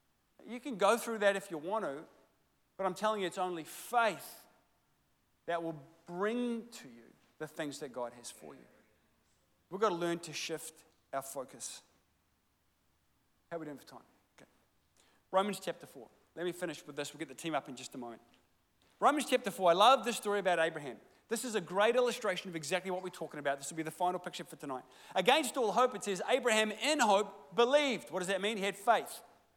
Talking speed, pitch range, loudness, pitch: 210 wpm, 155-215 Hz, -34 LUFS, 180 Hz